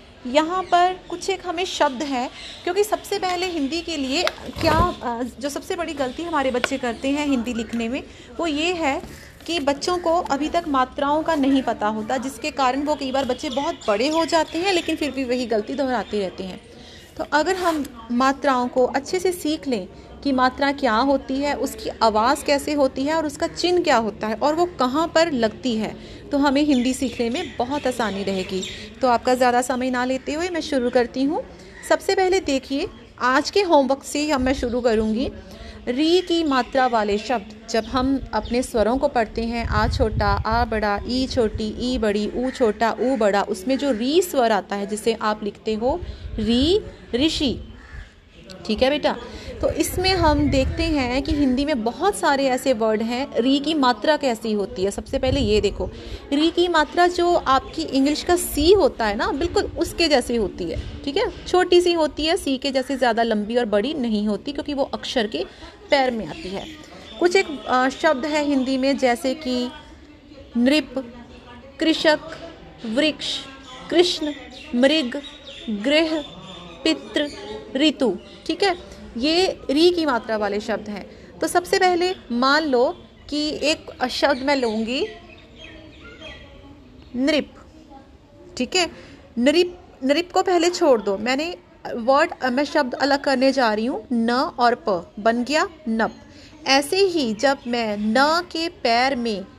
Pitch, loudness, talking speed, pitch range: 275 Hz, -21 LUFS, 170 wpm, 240-315 Hz